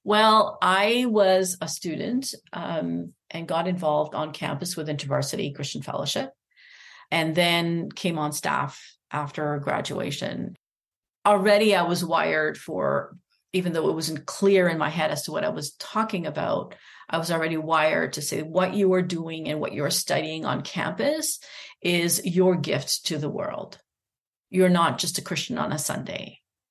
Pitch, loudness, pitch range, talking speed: 170 Hz, -25 LUFS, 155-190 Hz, 160 wpm